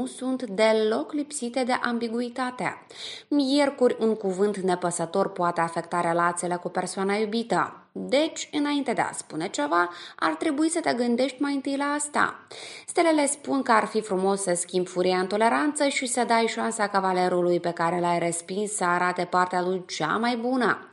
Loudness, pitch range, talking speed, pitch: -25 LUFS, 180-260 Hz, 165 wpm, 220 Hz